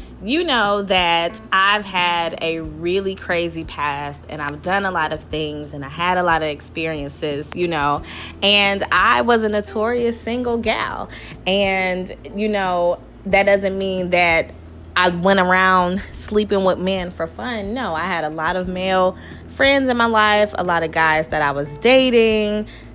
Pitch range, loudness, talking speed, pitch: 160-205 Hz, -18 LUFS, 175 wpm, 185 Hz